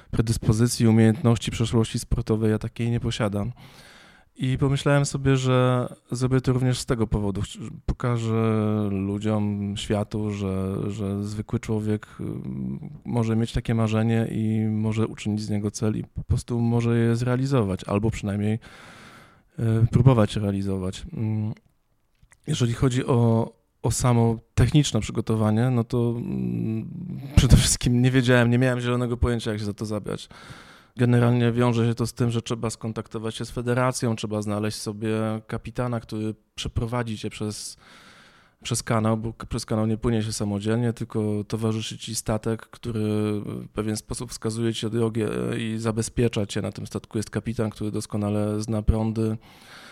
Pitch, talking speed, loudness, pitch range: 115 Hz, 145 wpm, -25 LUFS, 105-120 Hz